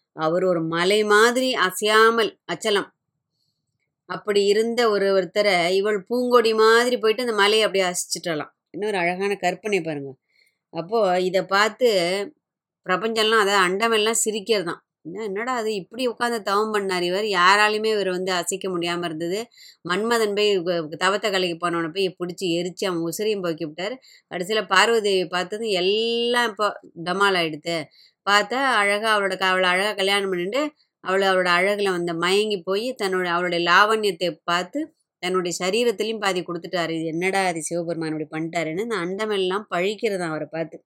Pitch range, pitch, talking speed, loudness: 175-215 Hz, 190 Hz, 140 wpm, -21 LUFS